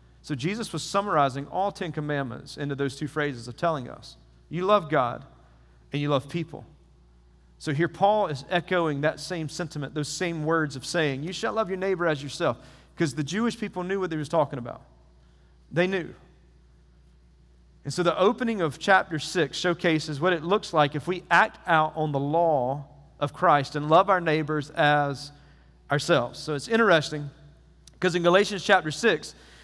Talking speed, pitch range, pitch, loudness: 180 wpm, 135-175 Hz, 155 Hz, -26 LUFS